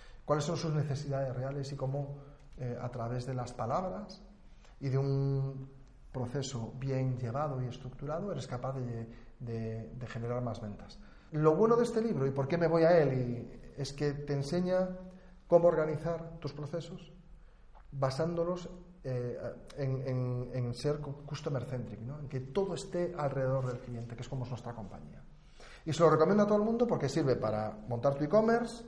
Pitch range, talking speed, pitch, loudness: 125-165 Hz, 175 wpm, 140 Hz, -33 LUFS